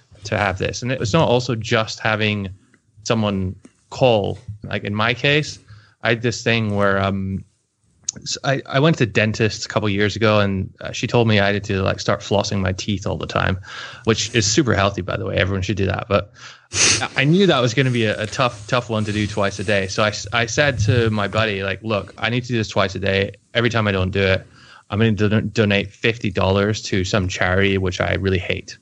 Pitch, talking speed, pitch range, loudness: 105 Hz, 240 wpm, 100-115 Hz, -19 LUFS